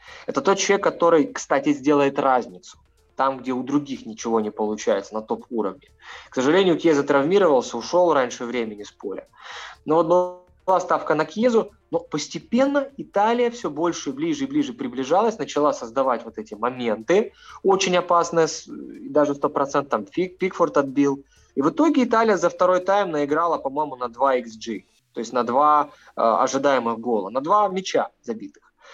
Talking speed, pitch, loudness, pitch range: 155 wpm, 165 Hz, -22 LUFS, 135-205 Hz